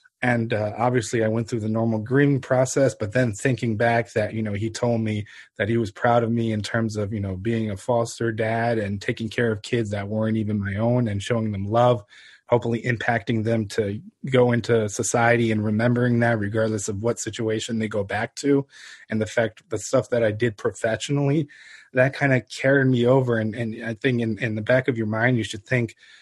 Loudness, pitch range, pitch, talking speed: -23 LUFS, 110-125 Hz, 115 Hz, 220 wpm